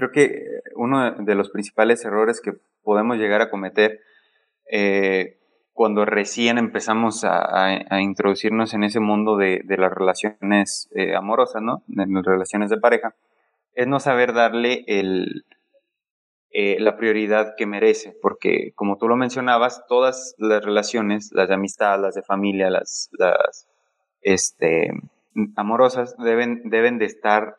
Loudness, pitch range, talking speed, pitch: -20 LUFS, 100-120 Hz, 145 wpm, 110 Hz